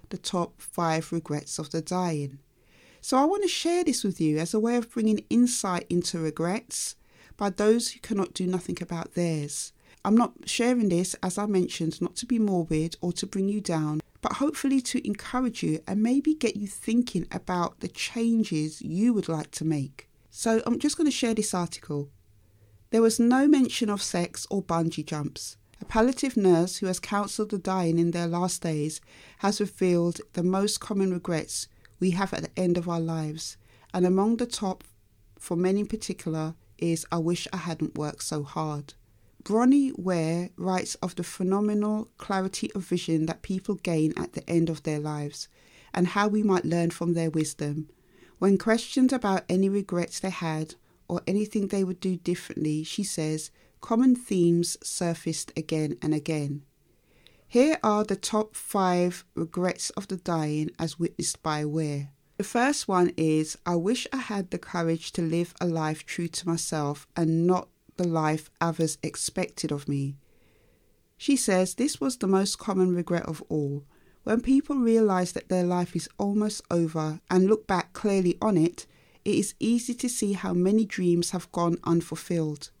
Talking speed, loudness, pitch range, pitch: 180 wpm, -27 LUFS, 160-205 Hz, 175 Hz